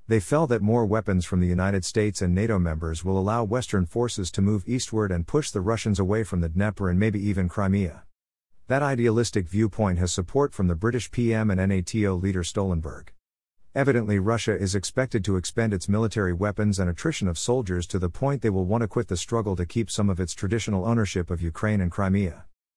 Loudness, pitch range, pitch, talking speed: -25 LUFS, 90-115 Hz, 100 Hz, 205 wpm